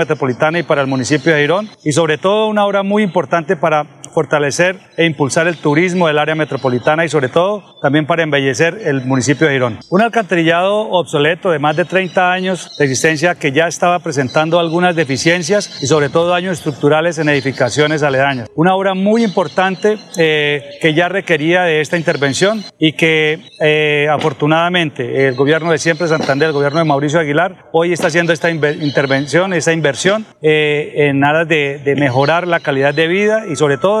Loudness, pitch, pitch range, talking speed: -14 LUFS, 160 Hz, 145-175 Hz, 180 wpm